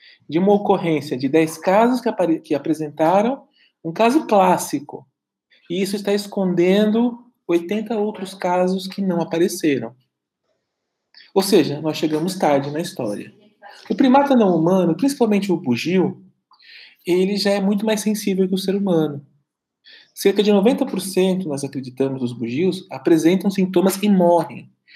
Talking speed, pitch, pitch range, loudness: 140 wpm, 185 Hz, 165-210 Hz, -19 LUFS